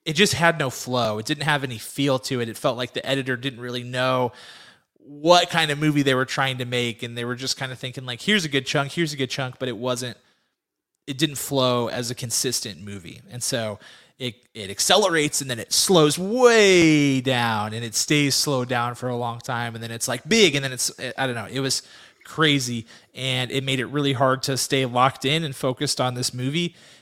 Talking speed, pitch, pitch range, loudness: 230 wpm, 130 Hz, 125-145 Hz, -22 LUFS